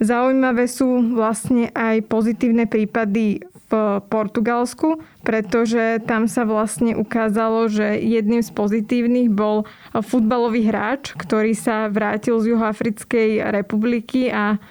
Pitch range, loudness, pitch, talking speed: 220-240 Hz, -19 LUFS, 225 Hz, 110 wpm